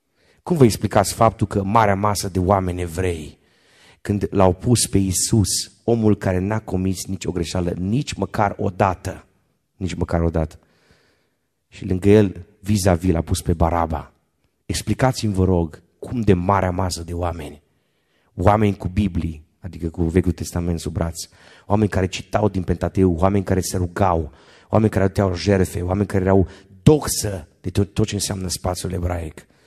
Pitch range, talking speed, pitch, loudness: 85-100 Hz, 160 wpm, 95 Hz, -20 LUFS